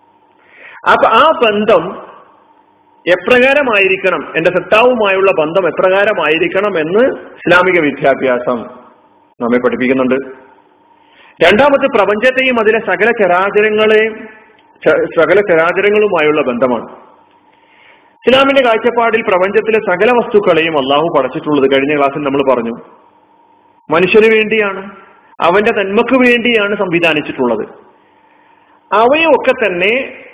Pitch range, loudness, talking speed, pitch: 165-245 Hz, -11 LUFS, 80 wpm, 210 Hz